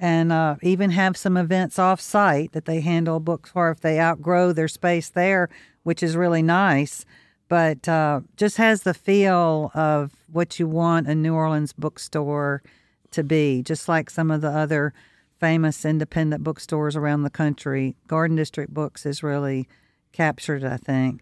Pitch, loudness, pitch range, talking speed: 160 Hz, -22 LUFS, 150-170 Hz, 165 wpm